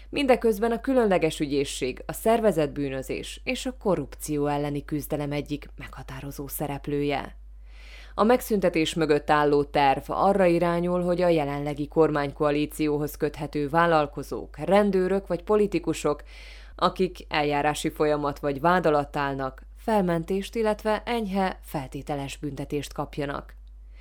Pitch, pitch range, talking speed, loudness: 150 Hz, 145-180 Hz, 105 wpm, -26 LUFS